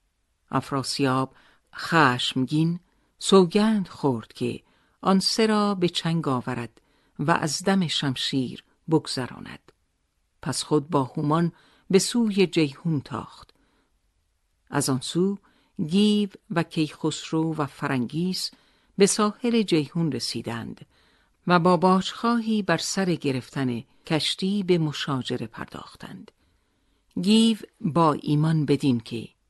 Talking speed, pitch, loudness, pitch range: 105 wpm, 160 Hz, -24 LUFS, 135-190 Hz